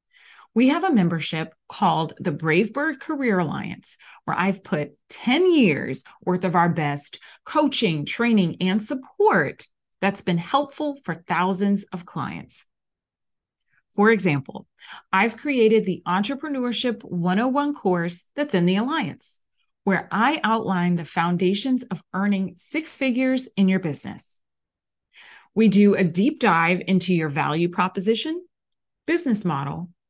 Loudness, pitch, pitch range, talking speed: -22 LUFS, 195 Hz, 175-250 Hz, 130 wpm